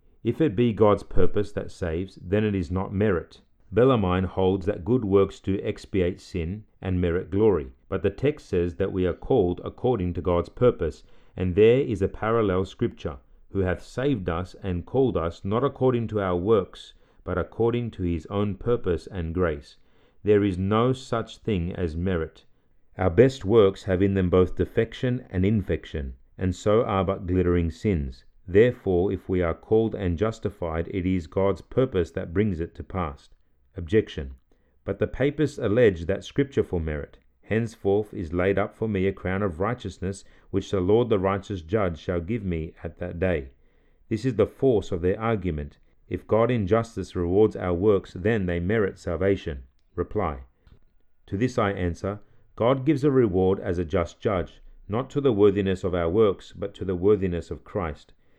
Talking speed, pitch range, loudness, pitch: 180 wpm, 85-105 Hz, -25 LUFS, 95 Hz